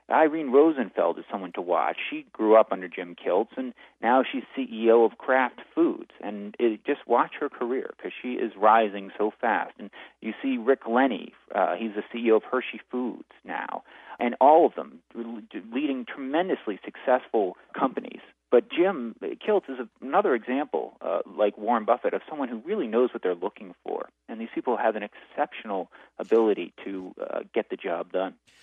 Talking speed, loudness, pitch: 180 wpm, -26 LUFS, 125 Hz